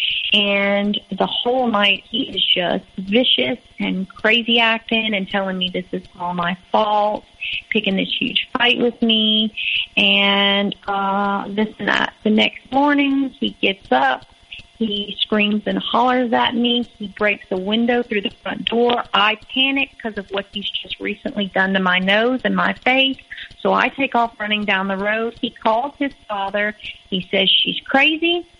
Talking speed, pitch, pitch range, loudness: 170 wpm, 215 Hz, 200-240 Hz, -18 LUFS